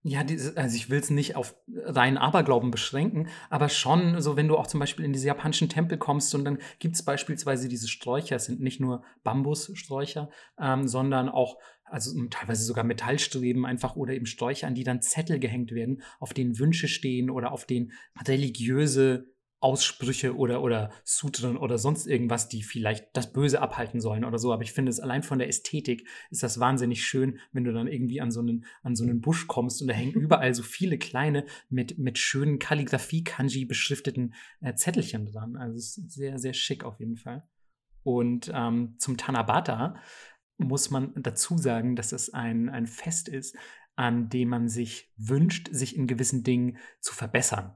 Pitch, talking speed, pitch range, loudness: 130 Hz, 185 wpm, 120-145 Hz, -28 LUFS